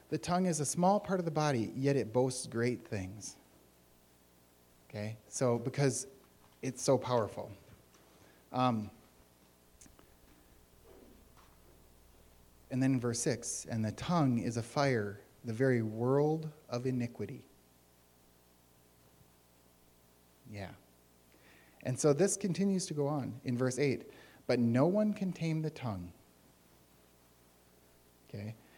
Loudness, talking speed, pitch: -34 LUFS, 115 wpm, 105 Hz